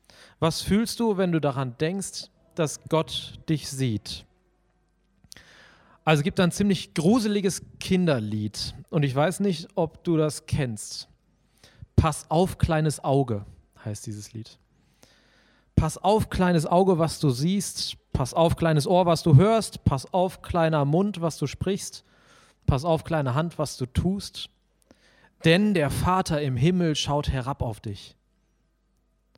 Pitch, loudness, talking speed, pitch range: 155 Hz, -25 LUFS, 145 wpm, 130-175 Hz